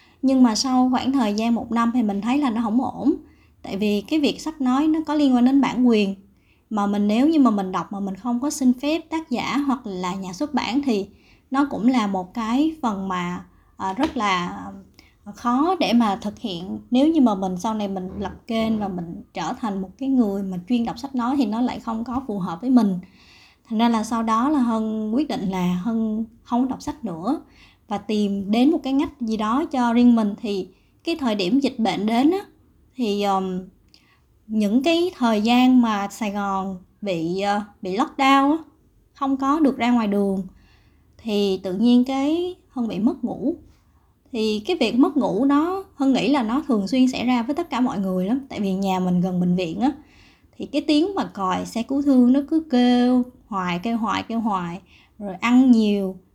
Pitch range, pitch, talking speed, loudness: 200-270 Hz, 235 Hz, 210 wpm, -22 LUFS